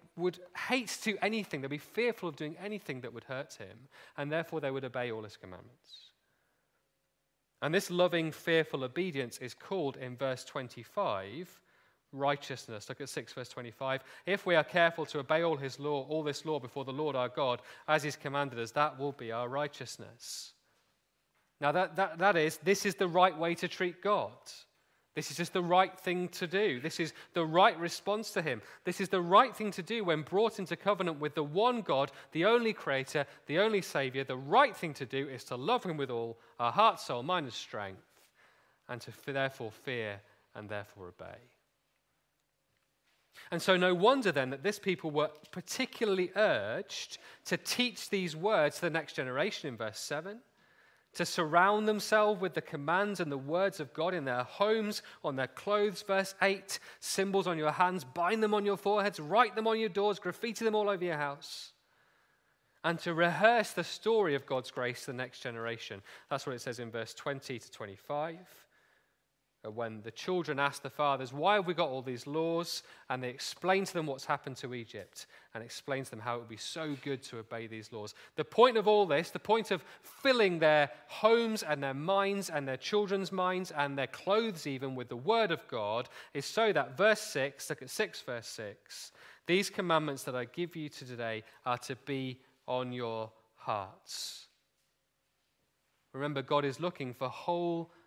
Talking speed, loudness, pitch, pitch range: 190 wpm, -33 LUFS, 155 Hz, 135-190 Hz